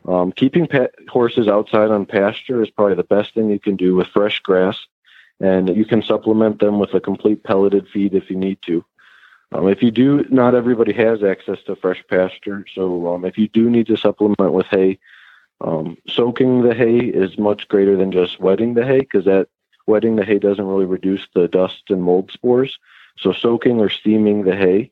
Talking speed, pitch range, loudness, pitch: 200 wpm, 95-115 Hz, -17 LUFS, 100 Hz